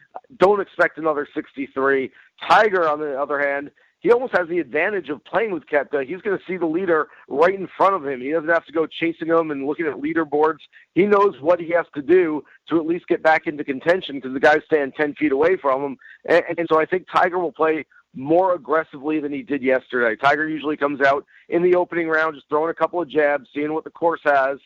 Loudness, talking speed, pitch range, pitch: -20 LUFS, 230 wpm, 145-180 Hz, 160 Hz